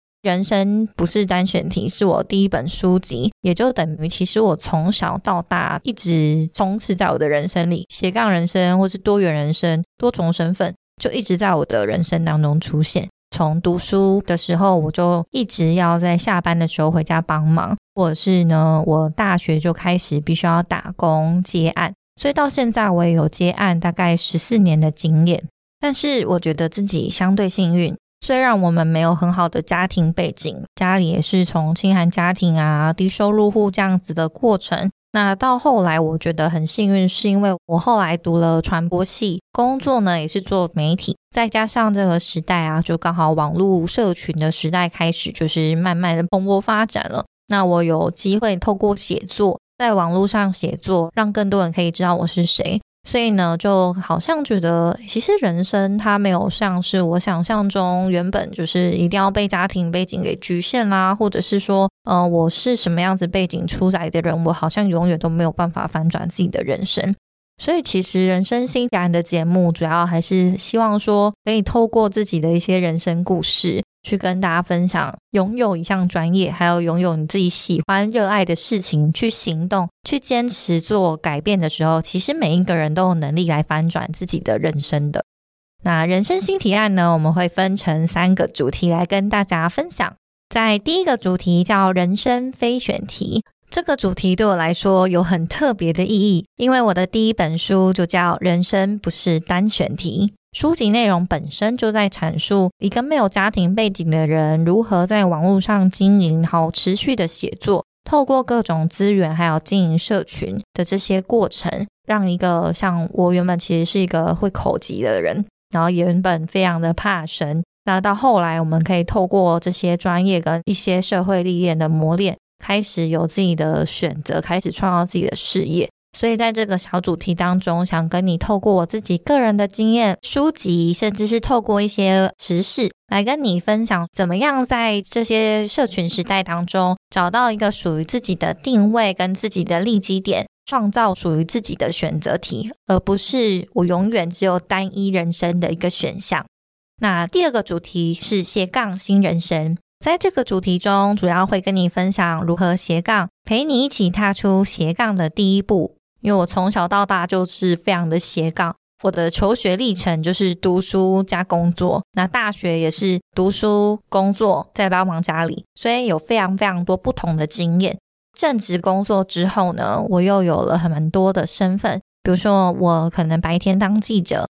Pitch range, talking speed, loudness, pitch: 170-205 Hz, 280 characters per minute, -18 LUFS, 185 Hz